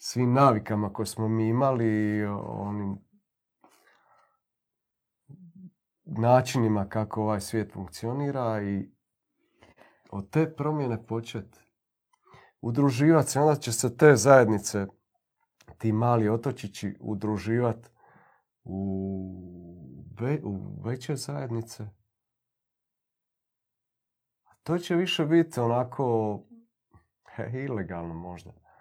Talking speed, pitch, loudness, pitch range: 85 wpm, 115 Hz, -27 LUFS, 105-135 Hz